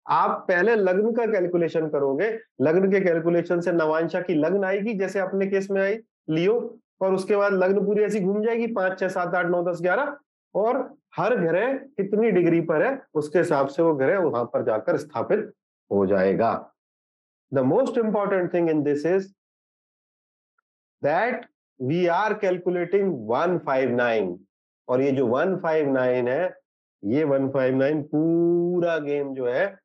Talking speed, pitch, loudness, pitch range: 160 wpm, 175 Hz, -23 LUFS, 145-195 Hz